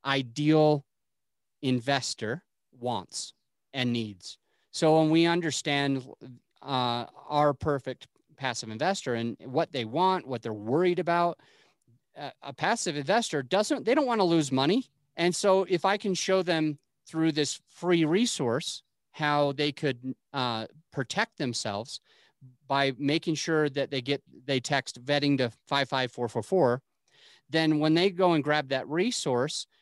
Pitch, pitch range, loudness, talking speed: 145 Hz, 130-165 Hz, -28 LUFS, 140 wpm